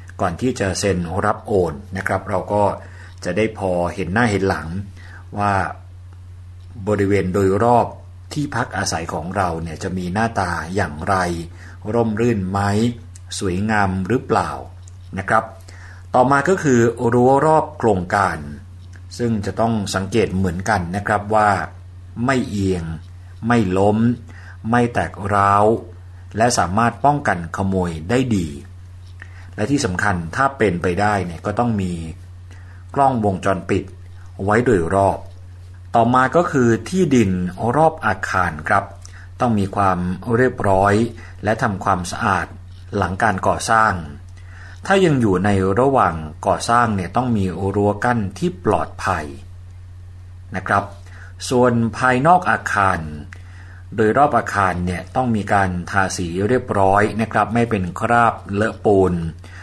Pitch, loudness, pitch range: 95 Hz, -19 LUFS, 90-110 Hz